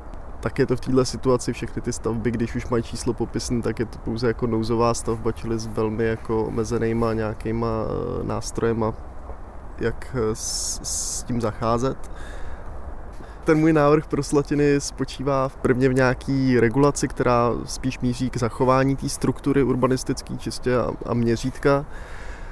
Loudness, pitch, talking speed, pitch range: -23 LUFS, 115 Hz, 150 wpm, 110-130 Hz